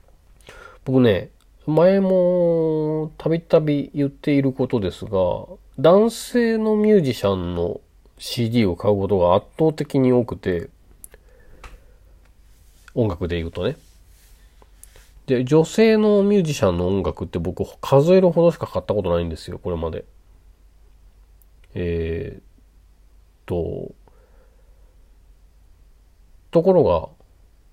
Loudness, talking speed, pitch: -20 LUFS, 210 characters per minute, 95 Hz